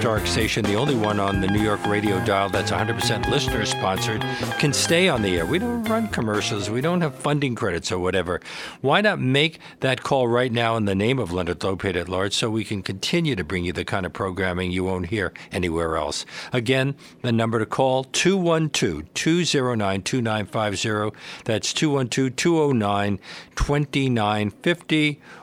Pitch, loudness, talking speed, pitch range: 115 Hz, -22 LUFS, 165 wpm, 100-135 Hz